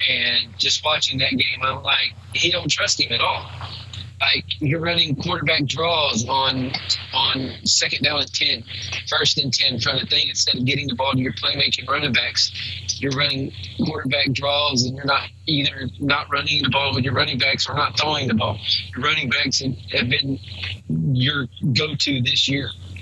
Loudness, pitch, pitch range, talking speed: -19 LUFS, 130 Hz, 110-140 Hz, 190 wpm